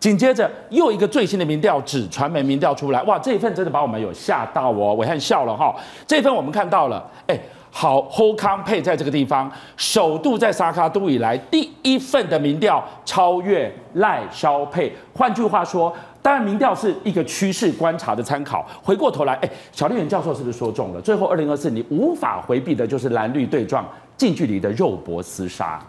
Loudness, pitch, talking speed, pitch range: -20 LUFS, 180 Hz, 315 characters per minute, 145-220 Hz